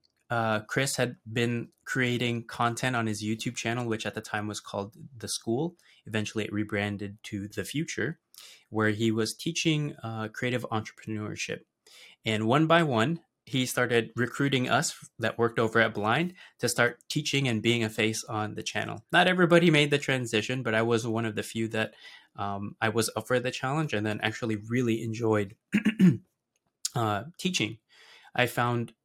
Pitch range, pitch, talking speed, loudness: 110-130 Hz, 115 Hz, 170 wpm, -28 LUFS